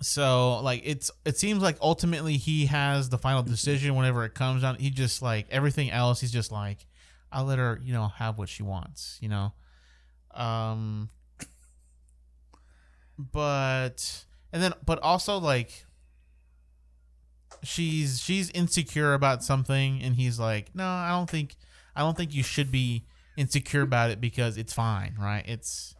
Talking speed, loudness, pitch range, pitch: 155 wpm, -28 LUFS, 100-145 Hz, 125 Hz